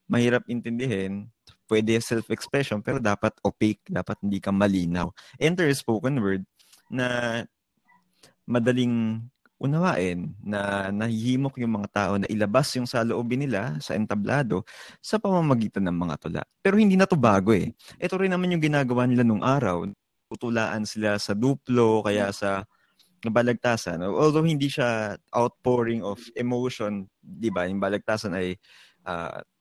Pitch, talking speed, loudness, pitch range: 115 Hz, 140 wpm, -25 LUFS, 100-125 Hz